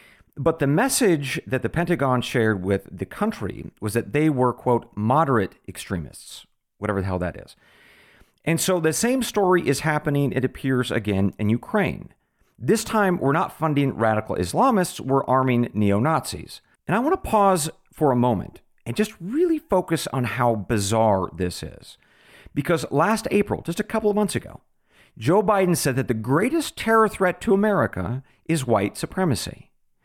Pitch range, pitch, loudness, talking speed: 120-190 Hz, 145 Hz, -22 LUFS, 170 wpm